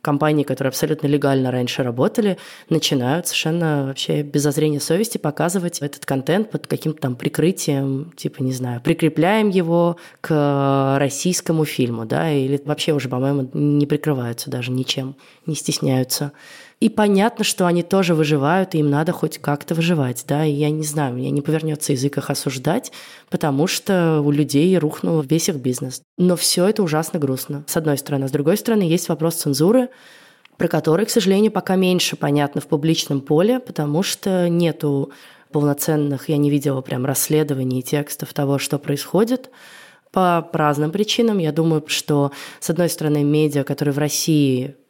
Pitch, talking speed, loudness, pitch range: 150 Hz, 160 wpm, -19 LUFS, 140-170 Hz